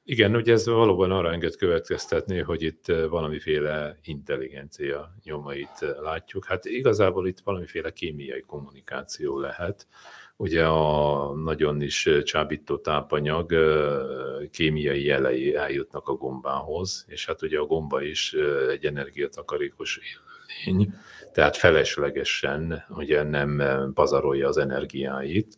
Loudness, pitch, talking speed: -25 LUFS, 80 Hz, 110 wpm